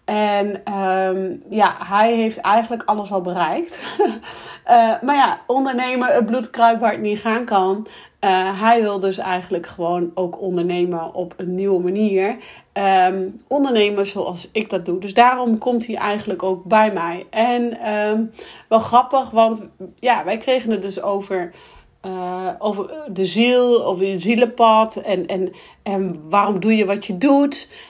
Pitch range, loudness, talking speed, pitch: 190-230 Hz, -19 LUFS, 155 wpm, 205 Hz